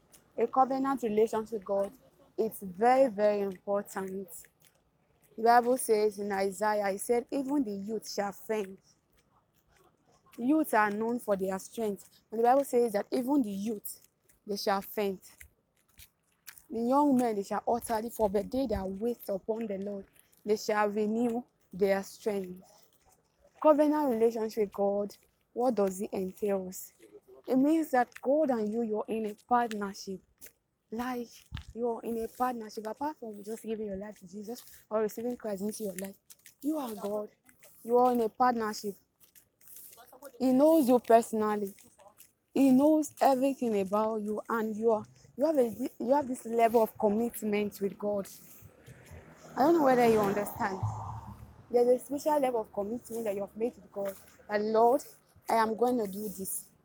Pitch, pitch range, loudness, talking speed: 220 Hz, 205-245 Hz, -30 LUFS, 160 wpm